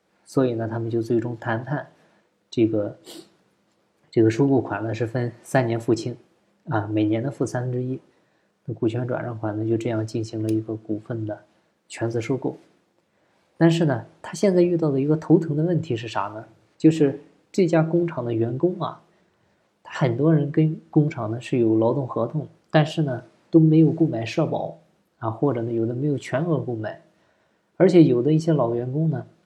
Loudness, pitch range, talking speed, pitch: -23 LUFS, 115-155 Hz, 265 characters per minute, 125 Hz